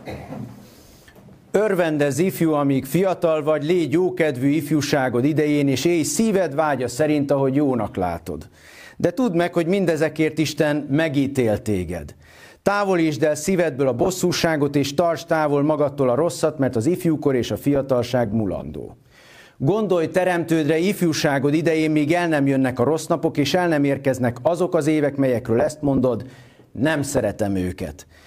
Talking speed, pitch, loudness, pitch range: 140 wpm, 150 Hz, -20 LUFS, 135-170 Hz